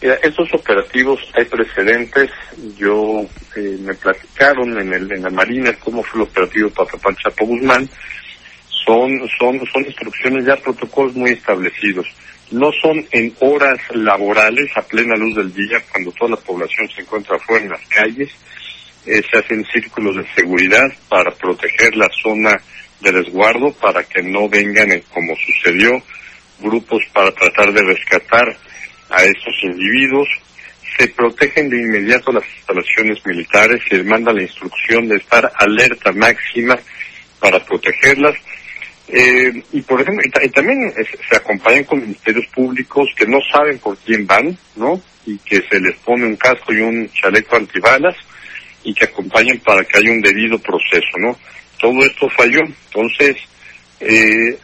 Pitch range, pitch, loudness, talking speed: 105-130 Hz, 115 Hz, -13 LUFS, 155 wpm